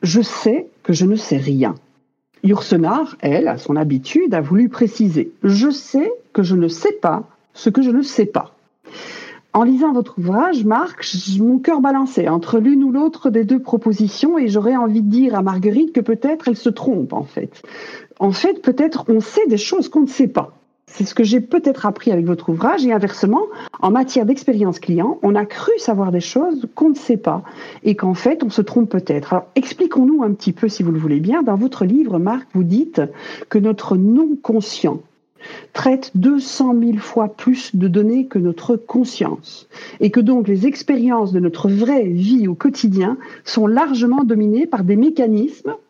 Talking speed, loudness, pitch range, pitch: 190 wpm, -16 LUFS, 200-270 Hz, 230 Hz